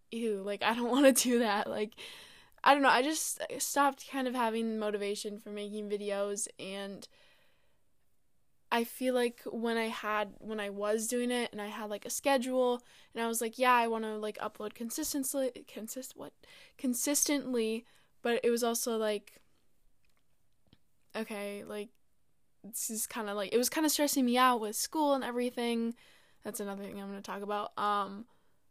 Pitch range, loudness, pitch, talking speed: 210-250 Hz, -32 LUFS, 230 Hz, 180 wpm